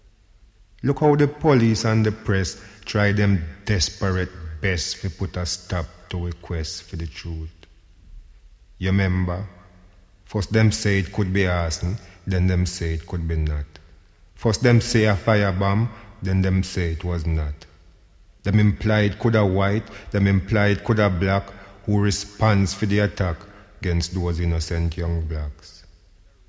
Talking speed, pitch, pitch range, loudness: 155 wpm, 95 Hz, 85-105 Hz, -22 LUFS